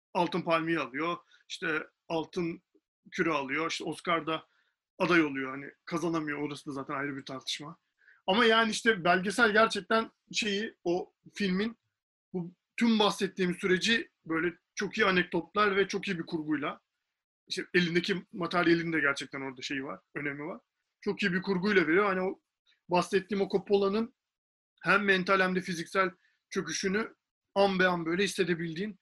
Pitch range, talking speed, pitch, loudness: 165-200 Hz, 145 wpm, 185 Hz, -30 LUFS